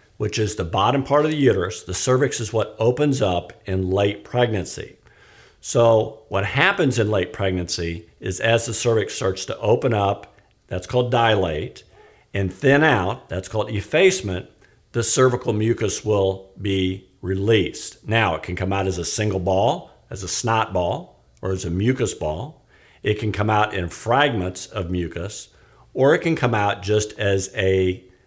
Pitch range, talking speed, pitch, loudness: 95-115 Hz, 170 wpm, 105 Hz, -21 LUFS